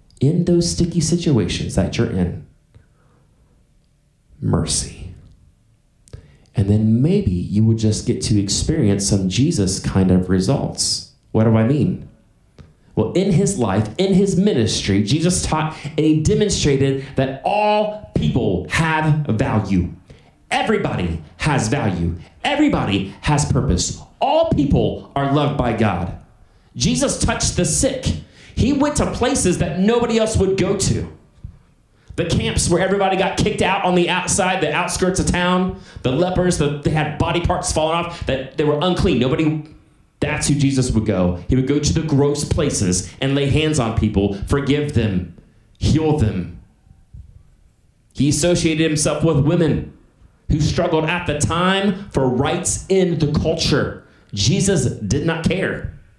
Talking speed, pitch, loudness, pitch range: 145 wpm, 145 Hz, -18 LUFS, 110-175 Hz